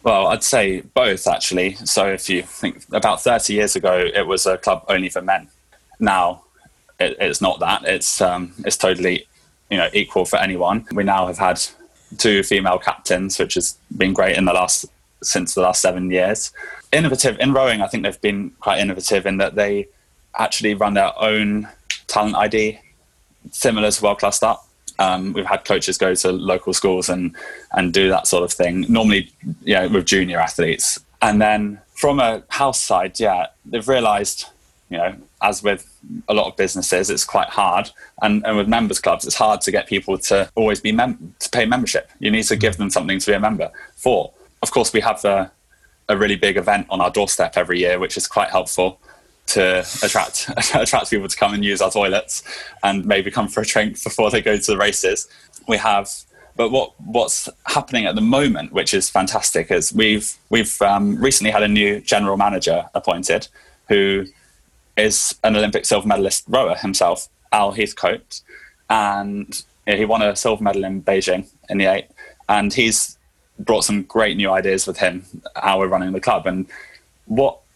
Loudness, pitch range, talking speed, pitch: -18 LUFS, 95-105 Hz, 190 wpm, 100 Hz